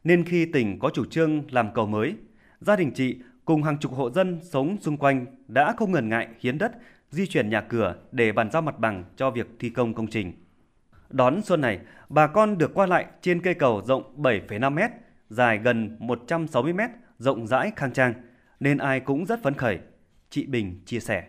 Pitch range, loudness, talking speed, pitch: 115-165 Hz, -25 LUFS, 200 wpm, 130 Hz